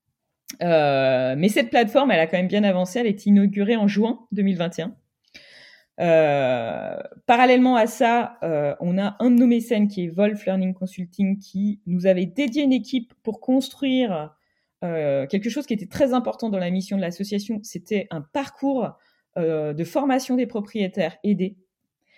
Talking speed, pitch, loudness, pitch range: 165 wpm, 205 Hz, -22 LUFS, 180-240 Hz